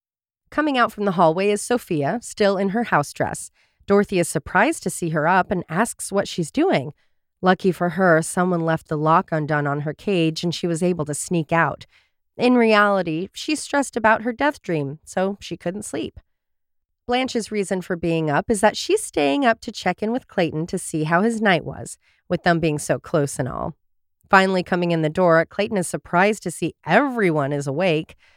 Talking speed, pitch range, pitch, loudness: 200 wpm, 160-210 Hz, 180 Hz, -21 LUFS